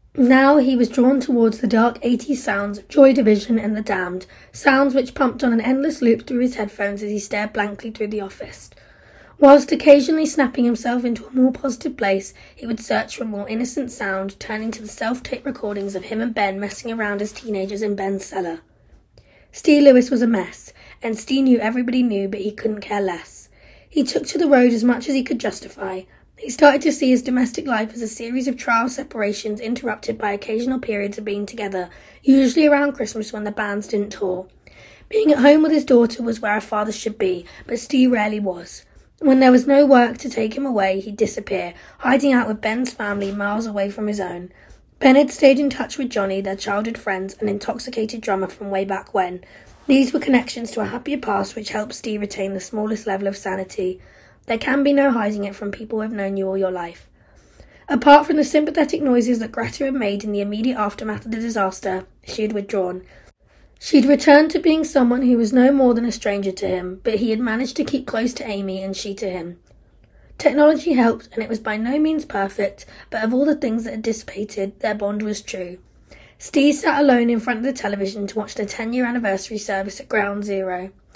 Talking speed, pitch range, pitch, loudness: 215 wpm, 205-265 Hz, 225 Hz, -19 LUFS